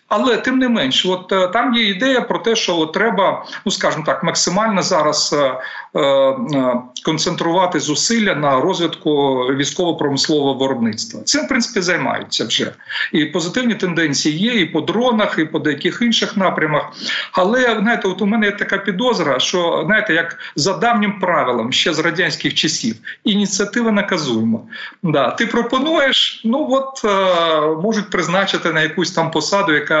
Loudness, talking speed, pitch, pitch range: -16 LUFS, 150 wpm, 185 Hz, 155-220 Hz